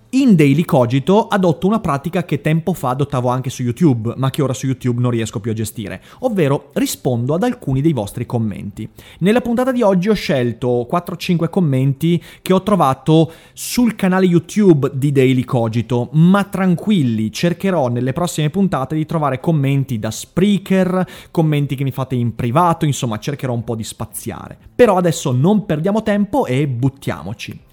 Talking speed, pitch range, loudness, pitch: 165 wpm, 125-185 Hz, -17 LUFS, 150 Hz